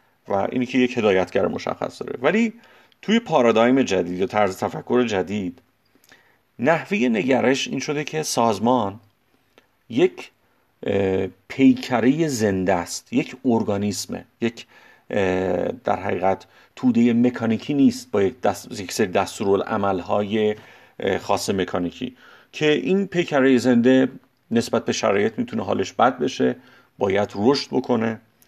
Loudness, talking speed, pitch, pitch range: -21 LUFS, 120 wpm, 120 Hz, 100-130 Hz